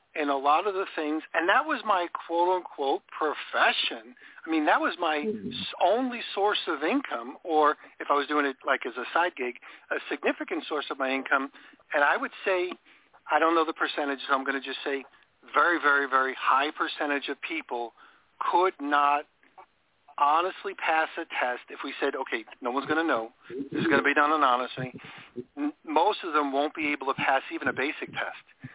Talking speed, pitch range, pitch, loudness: 195 wpm, 140-185 Hz, 150 Hz, -27 LUFS